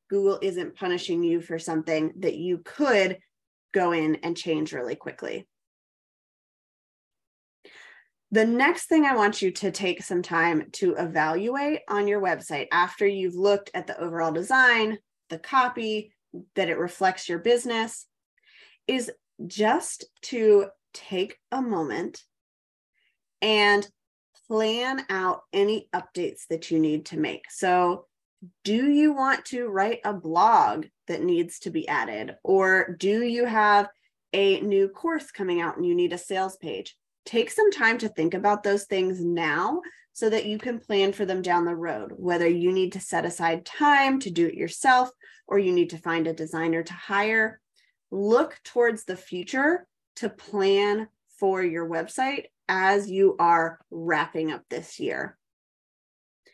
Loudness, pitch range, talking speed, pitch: -25 LUFS, 175-230 Hz, 150 wpm, 195 Hz